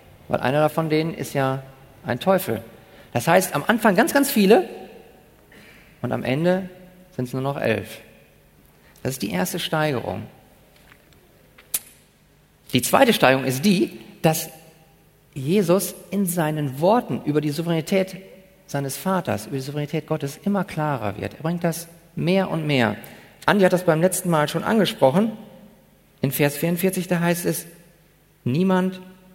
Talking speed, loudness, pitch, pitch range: 145 wpm, -22 LUFS, 165 Hz, 140-185 Hz